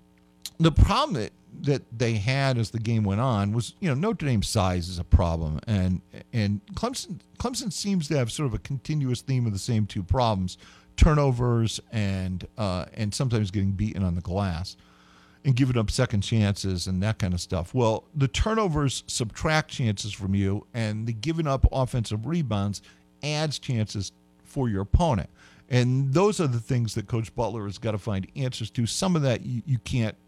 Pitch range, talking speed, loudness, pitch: 95-130 Hz, 190 wpm, -26 LUFS, 110 Hz